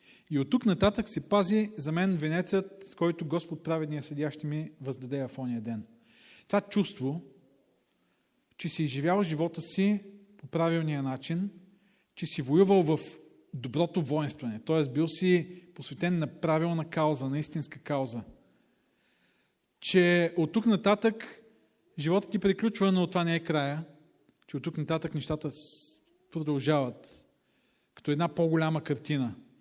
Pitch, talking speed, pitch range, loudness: 165 Hz, 135 wpm, 150-190 Hz, -30 LUFS